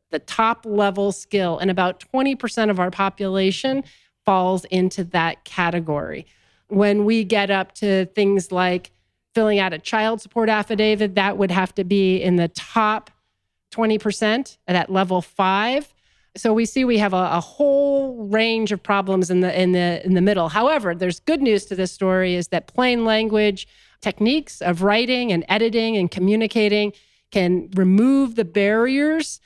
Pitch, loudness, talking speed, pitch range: 205 Hz, -20 LUFS, 160 wpm, 185-225 Hz